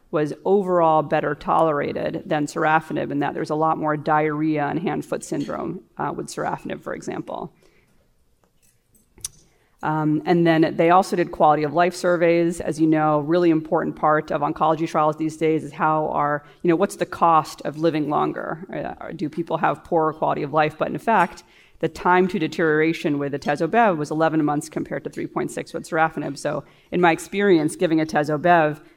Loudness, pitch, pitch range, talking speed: -21 LUFS, 160 Hz, 155-170 Hz, 175 wpm